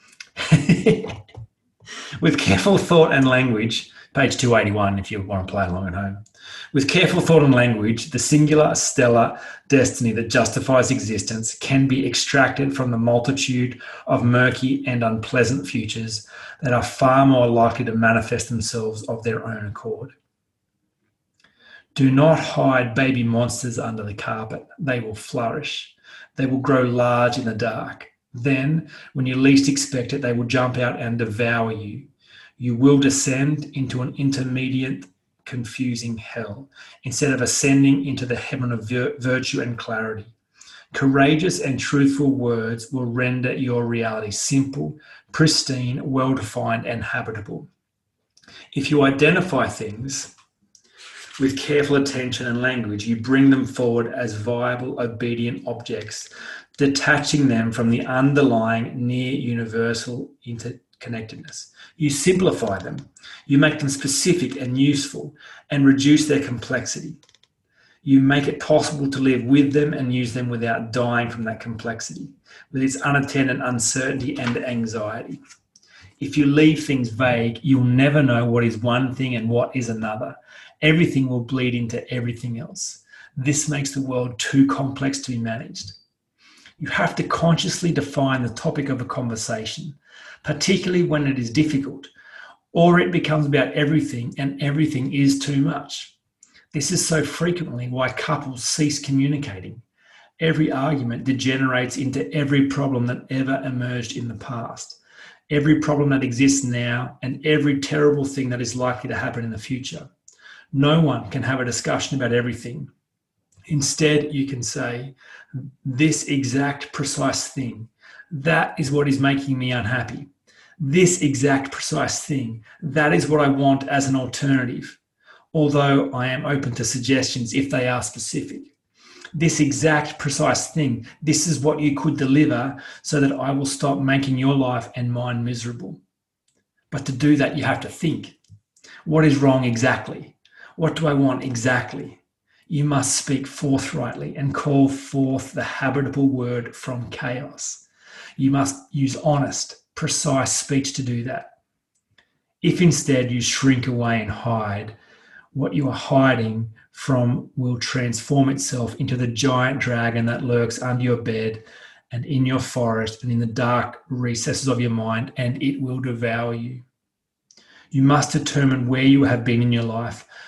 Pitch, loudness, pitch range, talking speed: 130 Hz, -21 LUFS, 120-140 Hz, 150 wpm